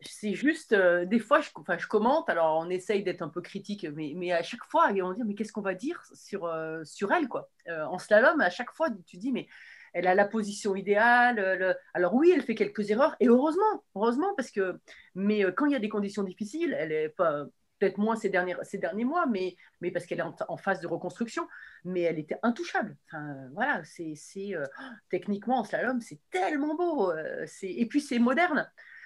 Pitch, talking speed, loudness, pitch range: 205 Hz, 225 wpm, -28 LUFS, 180-260 Hz